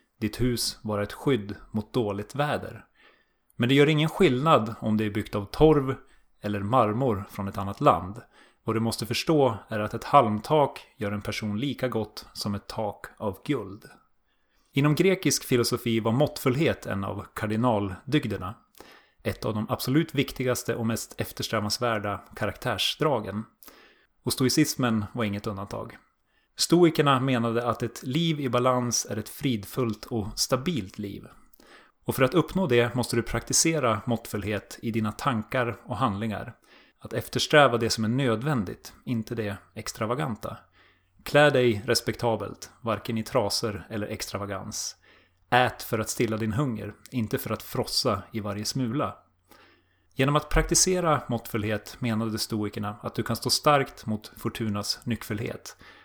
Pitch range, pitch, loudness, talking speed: 105-130 Hz, 115 Hz, -26 LUFS, 145 wpm